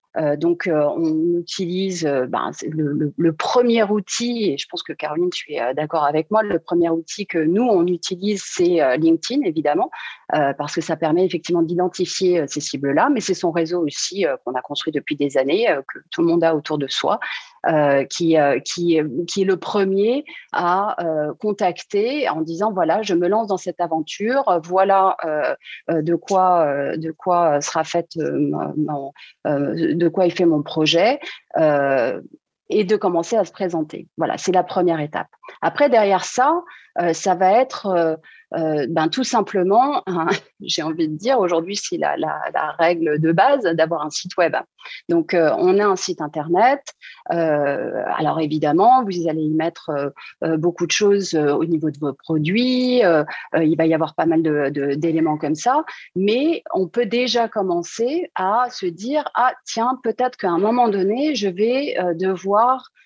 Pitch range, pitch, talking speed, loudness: 160-210 Hz, 175 Hz, 190 wpm, -20 LUFS